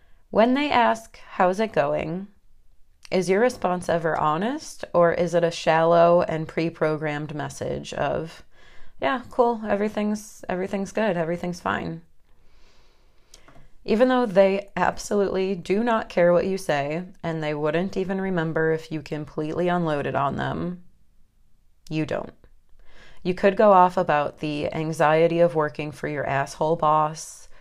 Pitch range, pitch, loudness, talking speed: 155-195 Hz, 170 Hz, -23 LUFS, 135 wpm